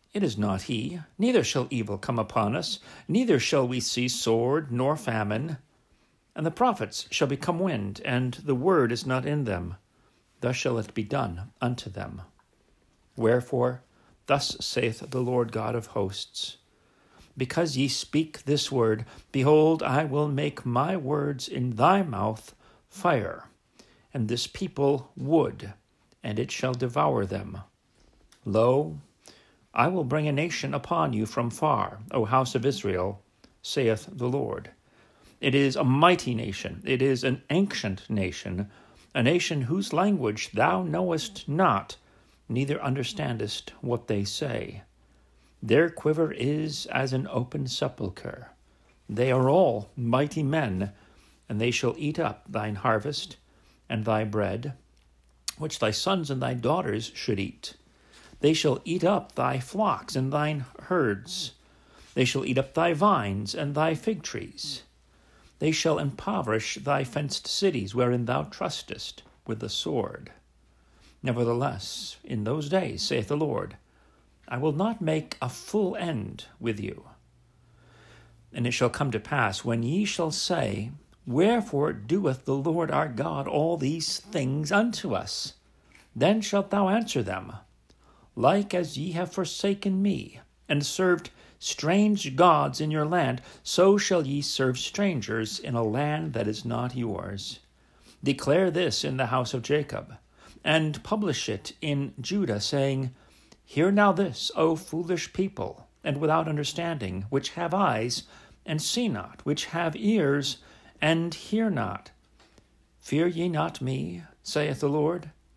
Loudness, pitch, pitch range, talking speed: -27 LUFS, 135 Hz, 115-160 Hz, 145 wpm